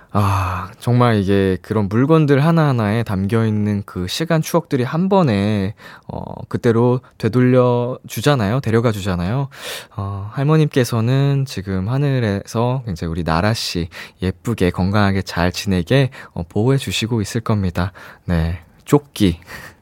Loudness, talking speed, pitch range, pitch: -18 LUFS, 285 characters per minute, 95-130 Hz, 110 Hz